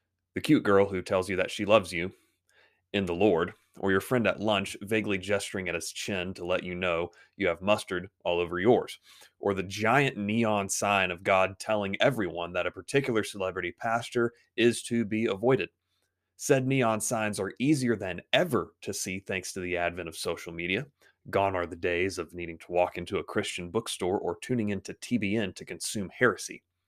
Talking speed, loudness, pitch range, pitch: 190 wpm, -29 LUFS, 90-110 Hz, 95 Hz